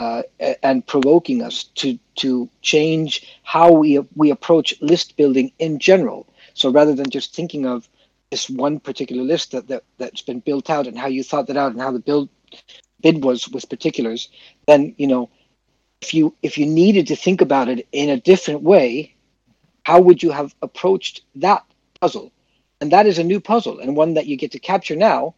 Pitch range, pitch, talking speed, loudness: 135-165 Hz, 150 Hz, 195 wpm, -17 LUFS